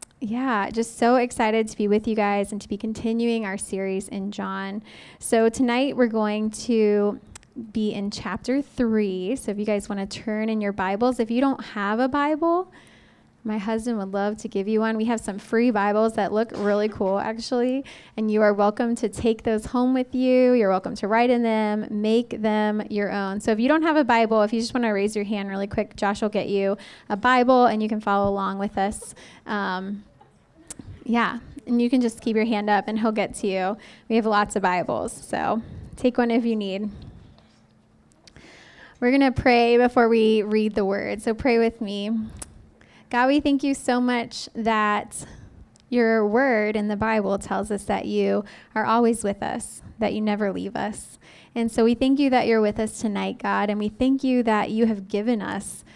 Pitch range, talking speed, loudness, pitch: 205-235 Hz, 210 wpm, -23 LUFS, 220 Hz